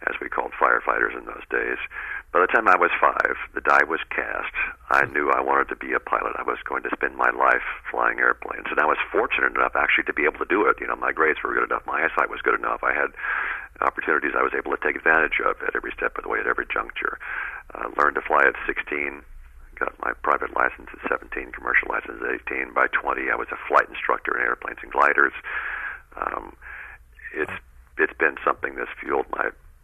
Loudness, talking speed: -23 LUFS, 225 wpm